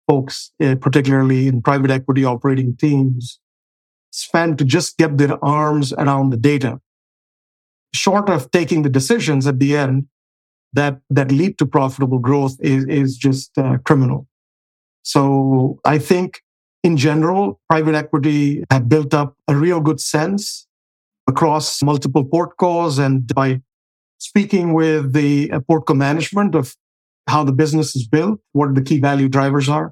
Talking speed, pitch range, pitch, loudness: 145 wpm, 135-155 Hz, 145 Hz, -16 LUFS